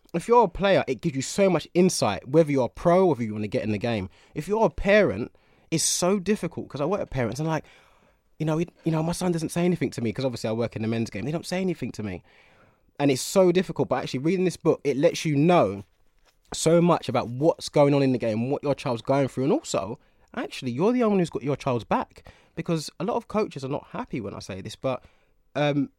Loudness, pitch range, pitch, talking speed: -25 LUFS, 125-175 Hz, 145 Hz, 270 wpm